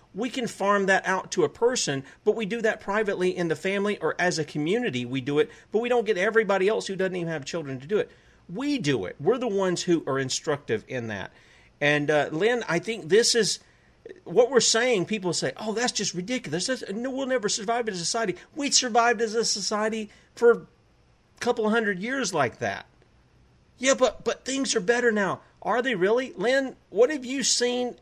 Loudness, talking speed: -25 LUFS, 210 wpm